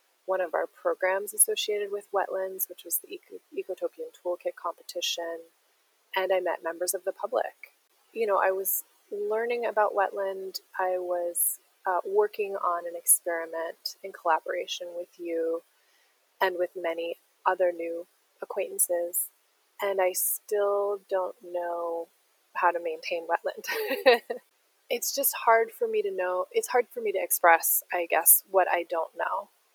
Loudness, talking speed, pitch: -28 LUFS, 145 wpm, 190 Hz